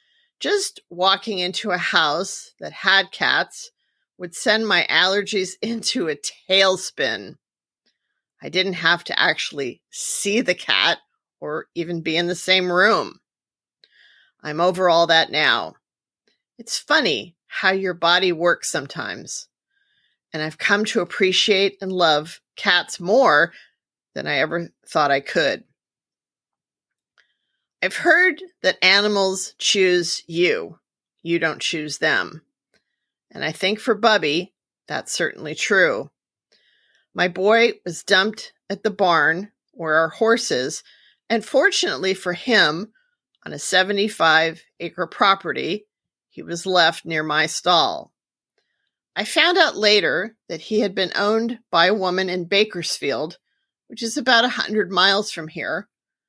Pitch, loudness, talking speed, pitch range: 190 Hz, -19 LUFS, 130 wpm, 175-220 Hz